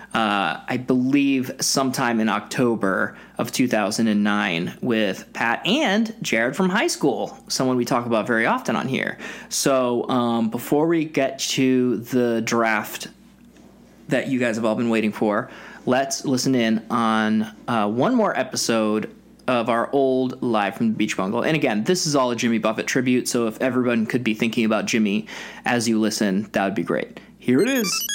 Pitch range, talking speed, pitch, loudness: 110-135 Hz, 175 wpm, 120 Hz, -21 LUFS